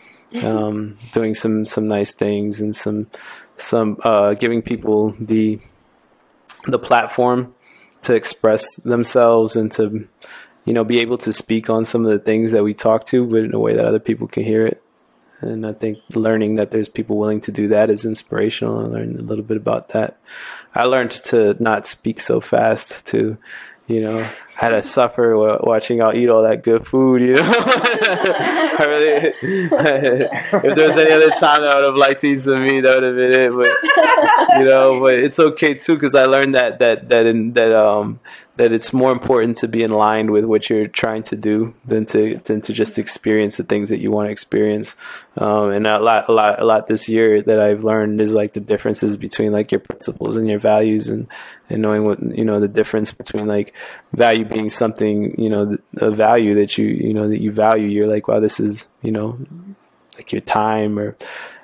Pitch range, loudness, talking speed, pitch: 105-120 Hz, -16 LUFS, 205 wpm, 110 Hz